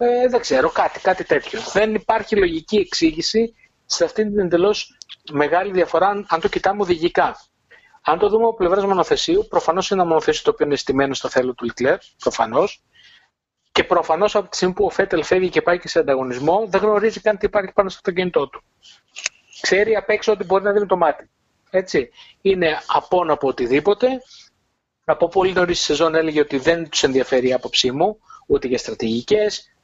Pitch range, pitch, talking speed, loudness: 165-215 Hz, 195 Hz, 185 wpm, -19 LUFS